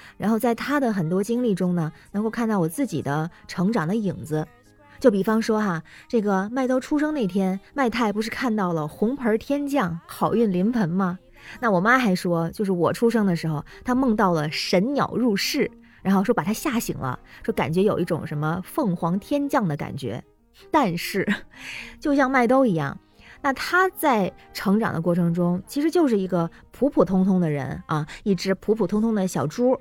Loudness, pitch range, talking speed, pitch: -23 LUFS, 170-235 Hz, 275 characters per minute, 200 Hz